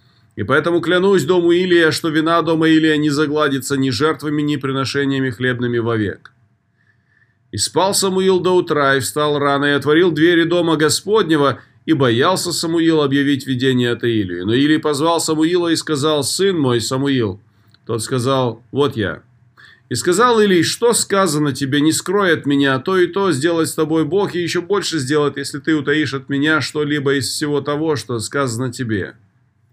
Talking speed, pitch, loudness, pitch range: 170 wpm, 150 Hz, -16 LUFS, 130-165 Hz